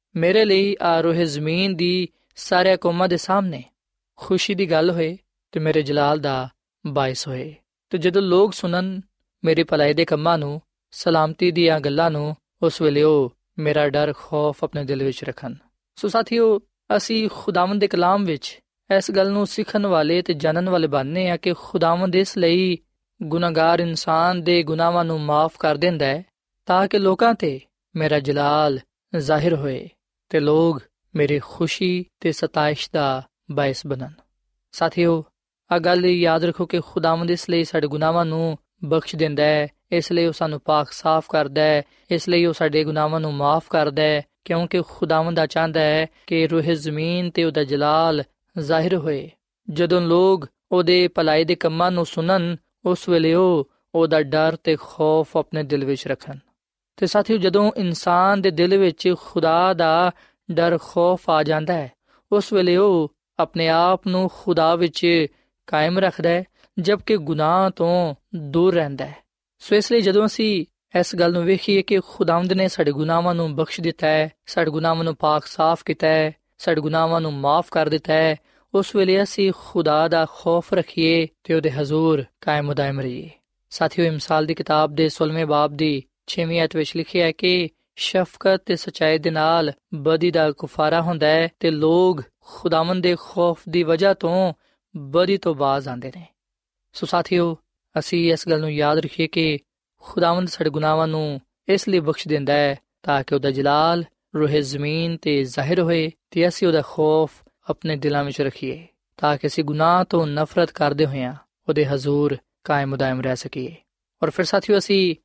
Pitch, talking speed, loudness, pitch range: 165 Hz, 160 wpm, -20 LUFS, 155-180 Hz